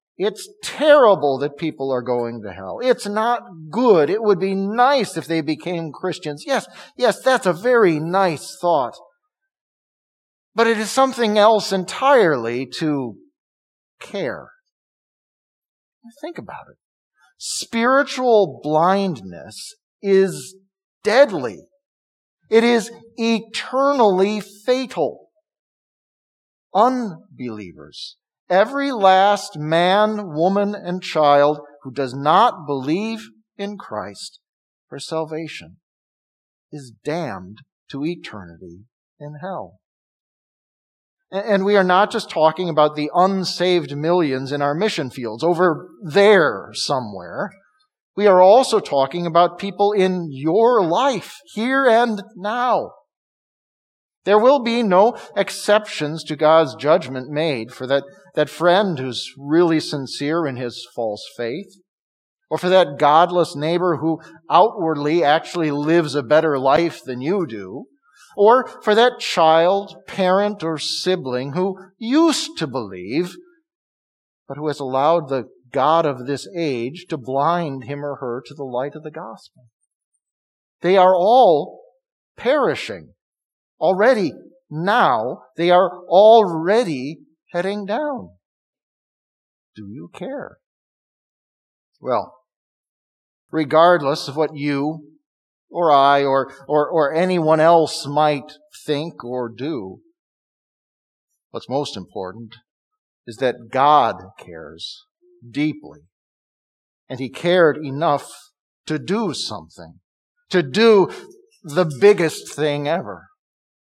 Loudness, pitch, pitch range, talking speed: -18 LUFS, 170 Hz, 140-205 Hz, 110 wpm